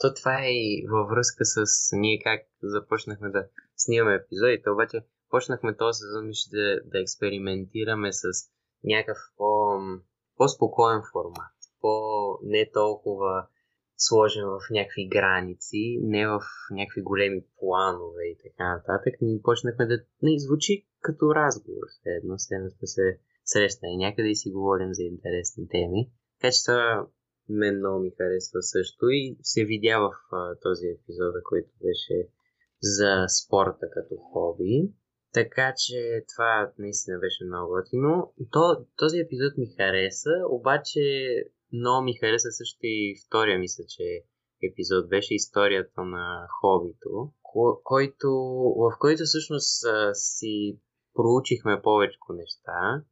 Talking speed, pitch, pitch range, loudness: 125 wpm, 110 Hz, 100-135 Hz, -26 LUFS